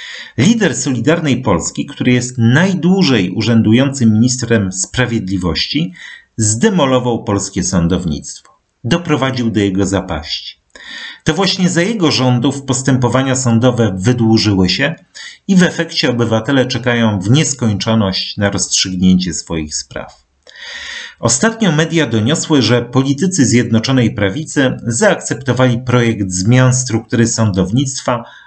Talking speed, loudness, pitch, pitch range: 100 wpm, -13 LUFS, 120 Hz, 110-140 Hz